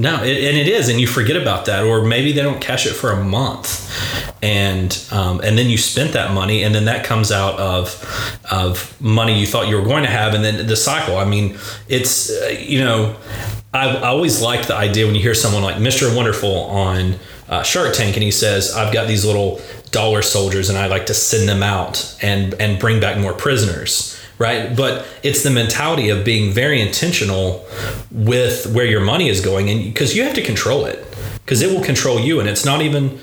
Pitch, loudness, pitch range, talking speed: 110 Hz, -16 LUFS, 100-130 Hz, 220 wpm